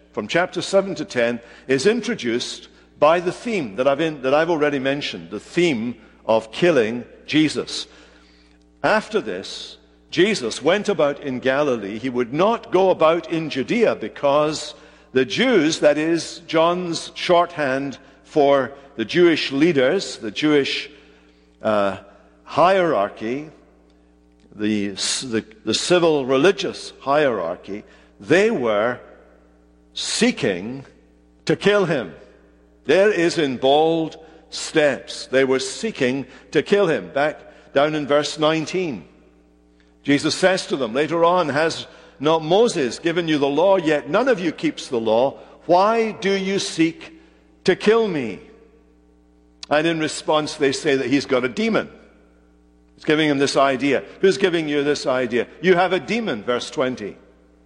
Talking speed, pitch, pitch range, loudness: 135 wpm, 145 Hz, 110-170 Hz, -20 LUFS